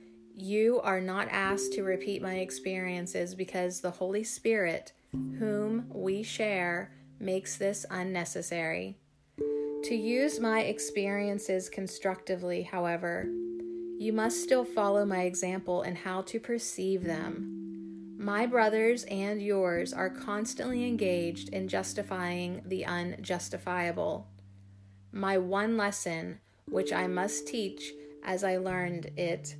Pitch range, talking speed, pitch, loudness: 170-205 Hz, 115 wpm, 185 Hz, -32 LUFS